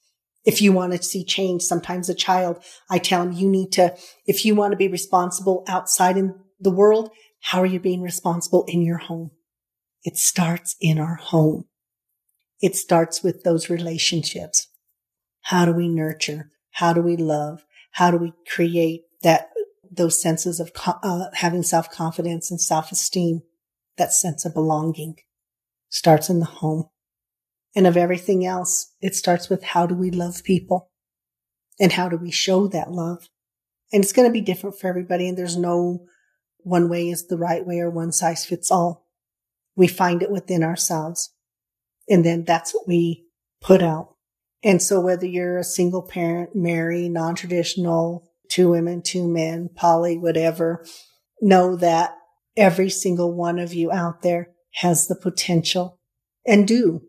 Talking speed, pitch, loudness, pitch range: 165 wpm, 175 Hz, -21 LUFS, 165-185 Hz